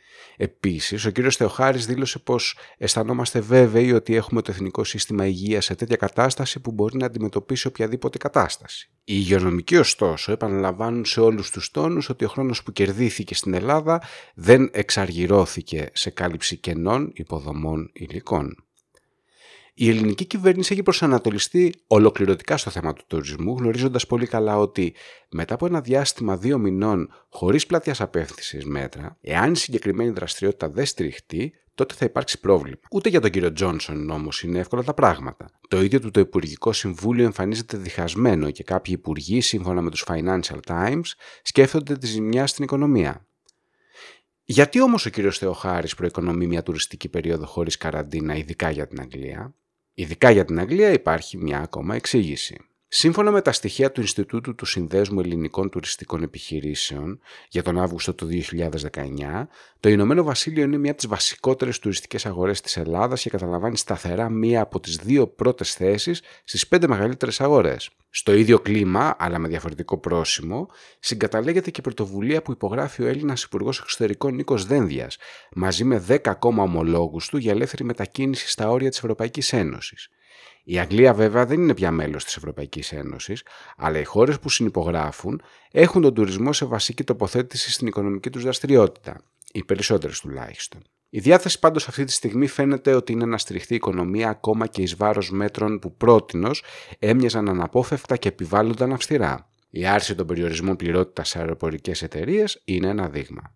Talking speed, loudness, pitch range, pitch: 155 wpm, -22 LUFS, 90-125 Hz, 105 Hz